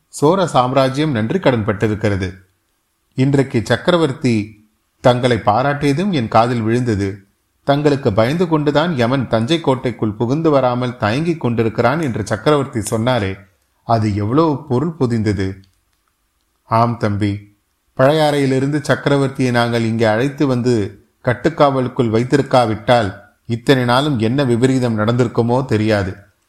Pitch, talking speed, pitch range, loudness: 120 Hz, 100 wpm, 105-135 Hz, -16 LUFS